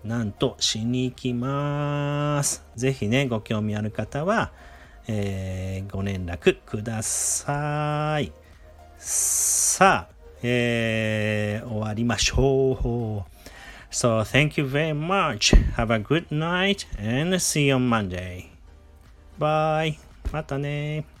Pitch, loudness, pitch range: 115 Hz, -24 LUFS, 95-145 Hz